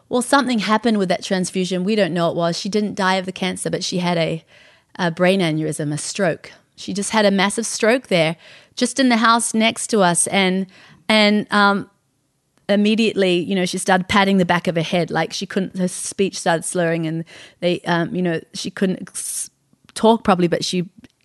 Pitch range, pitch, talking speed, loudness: 175-210 Hz, 190 Hz, 205 wpm, -19 LUFS